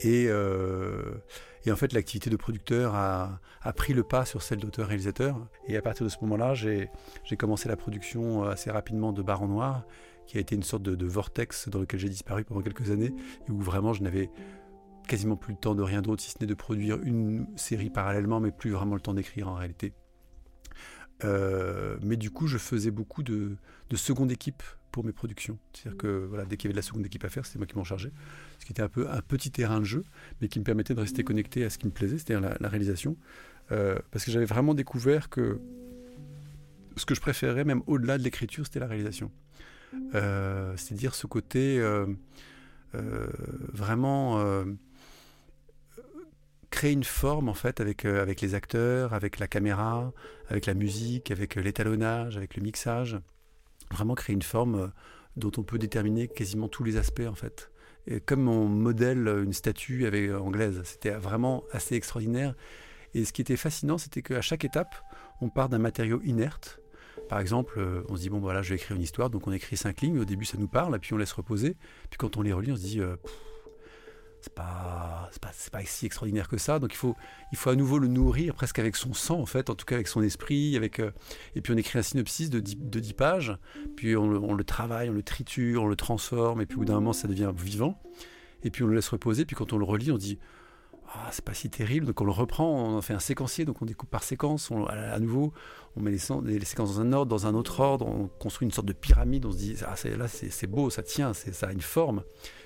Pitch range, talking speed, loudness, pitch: 100-130 Hz, 225 wpm, -30 LUFS, 110 Hz